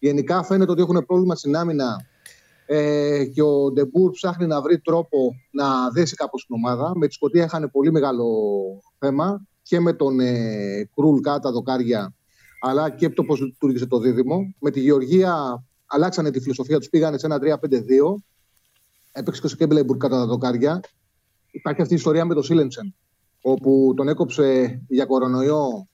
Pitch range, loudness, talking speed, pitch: 130-165 Hz, -20 LUFS, 165 wpm, 145 Hz